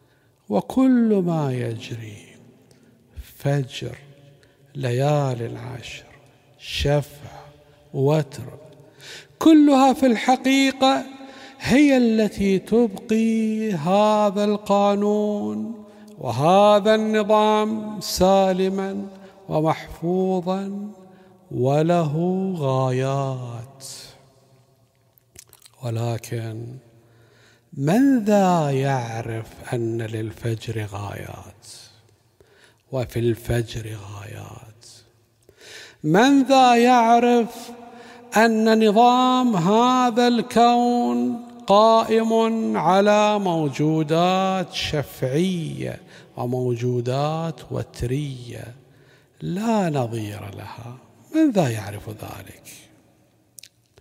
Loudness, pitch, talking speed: -20 LUFS, 155 Hz, 60 wpm